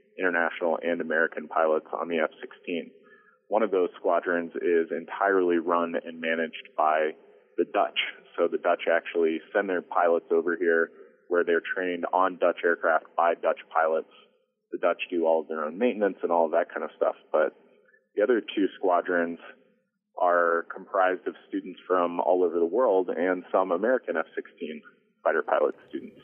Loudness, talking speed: -27 LUFS, 165 wpm